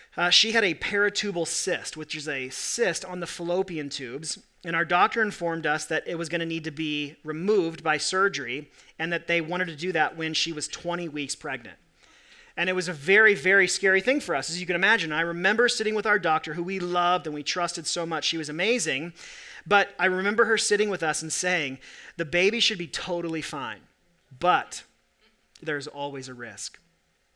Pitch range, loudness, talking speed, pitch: 155-190 Hz, -25 LUFS, 205 wpm, 170 Hz